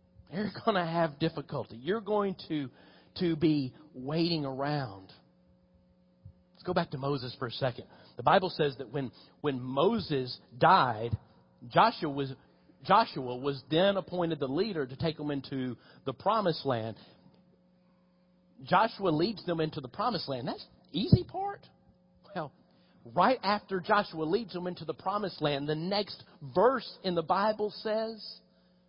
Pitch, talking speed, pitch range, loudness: 160 Hz, 145 wpm, 135-185 Hz, -31 LUFS